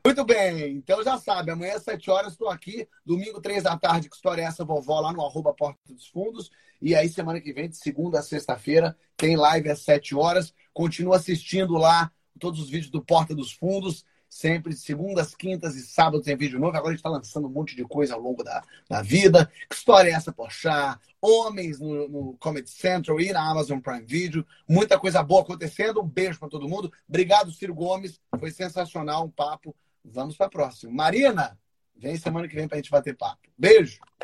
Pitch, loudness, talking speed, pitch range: 165 Hz, -24 LUFS, 205 wpm, 150-185 Hz